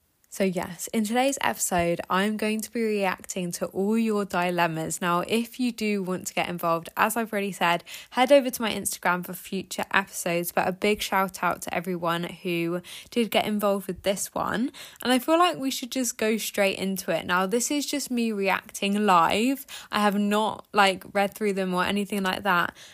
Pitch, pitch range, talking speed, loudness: 200 Hz, 180-225 Hz, 200 wpm, -26 LUFS